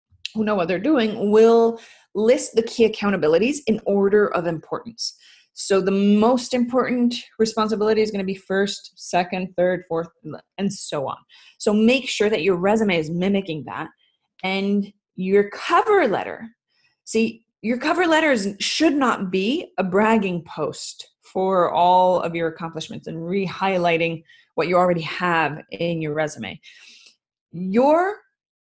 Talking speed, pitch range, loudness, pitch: 140 wpm, 180-230 Hz, -21 LUFS, 200 Hz